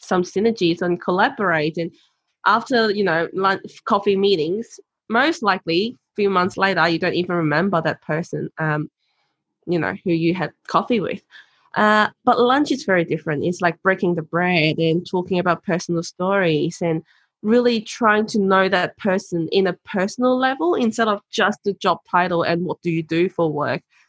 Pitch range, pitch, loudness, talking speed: 170-205 Hz, 185 Hz, -20 LUFS, 175 wpm